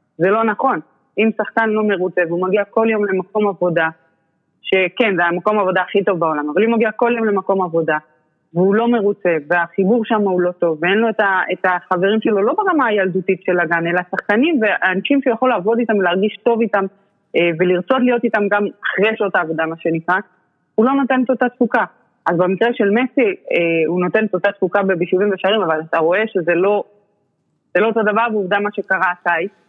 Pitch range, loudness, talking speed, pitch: 180-220 Hz, -17 LUFS, 190 wpm, 195 Hz